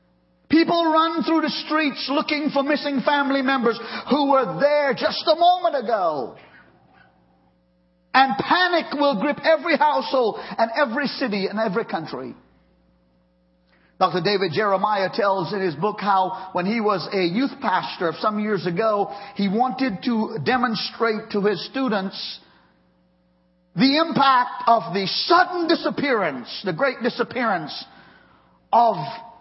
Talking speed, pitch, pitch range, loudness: 130 wpm, 230 Hz, 190-280 Hz, -21 LUFS